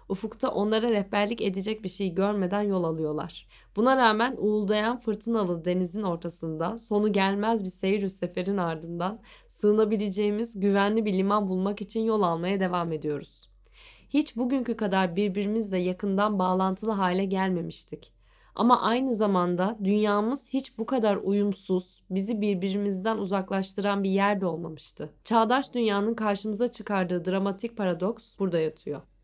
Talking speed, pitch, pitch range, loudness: 125 wpm, 200 Hz, 185-220 Hz, -27 LUFS